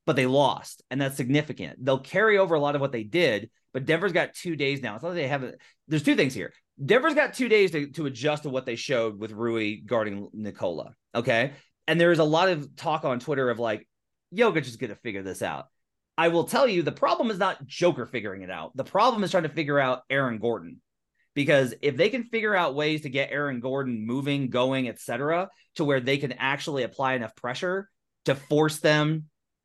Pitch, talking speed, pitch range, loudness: 140 Hz, 225 wpm, 125-165 Hz, -26 LUFS